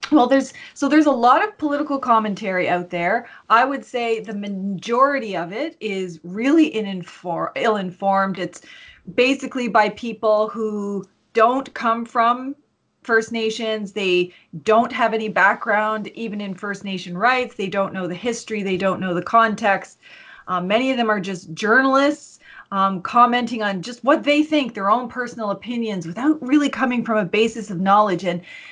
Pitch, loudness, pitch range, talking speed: 220 Hz, -20 LUFS, 195-250 Hz, 165 wpm